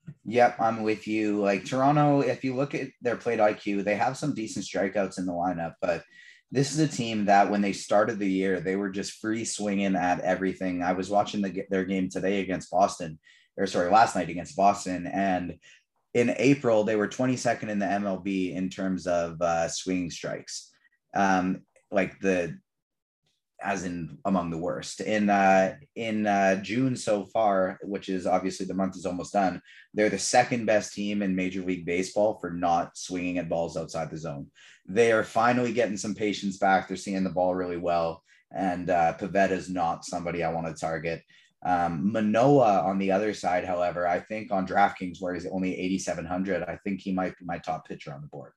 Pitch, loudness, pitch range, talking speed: 95 Hz, -27 LUFS, 90-105 Hz, 195 wpm